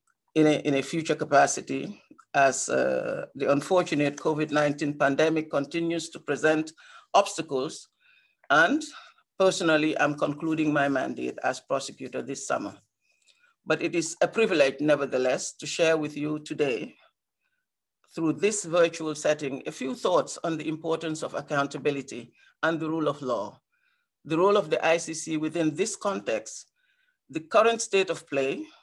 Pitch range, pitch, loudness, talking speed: 150-195 Hz, 160 Hz, -26 LUFS, 140 wpm